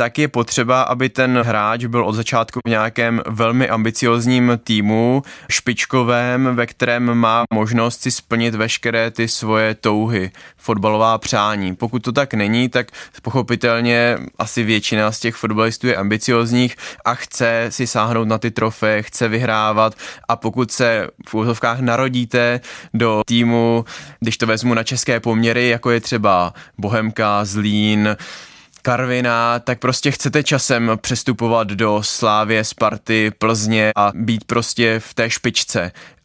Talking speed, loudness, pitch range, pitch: 140 wpm, -17 LUFS, 110-120 Hz, 115 Hz